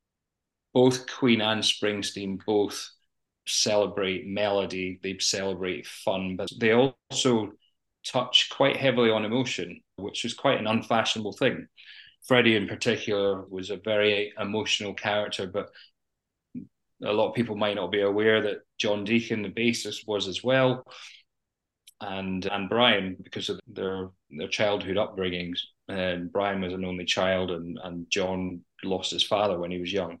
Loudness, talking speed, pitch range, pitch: -26 LUFS, 145 wpm, 95-110 Hz, 105 Hz